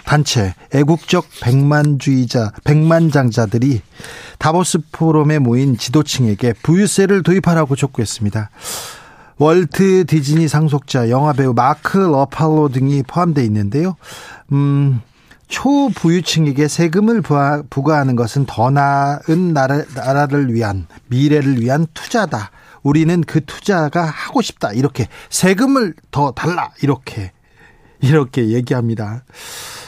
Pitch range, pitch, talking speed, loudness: 130-160 Hz, 145 Hz, 275 characters per minute, -15 LUFS